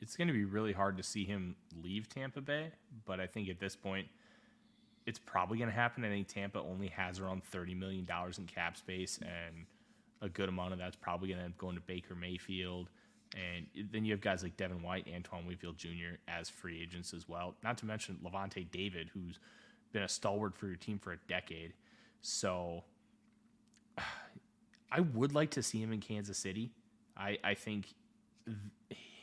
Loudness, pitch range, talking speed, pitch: -41 LUFS, 90-110 Hz, 190 wpm, 95 Hz